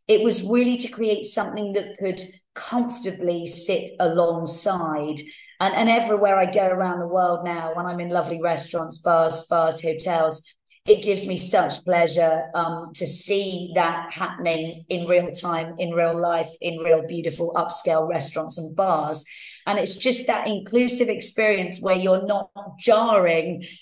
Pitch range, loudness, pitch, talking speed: 165-200 Hz, -22 LUFS, 175 Hz, 155 wpm